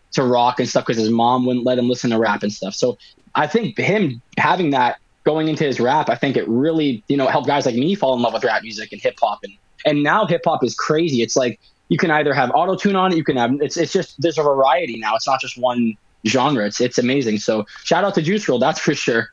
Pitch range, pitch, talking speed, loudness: 120-165 Hz, 140 Hz, 275 wpm, -18 LUFS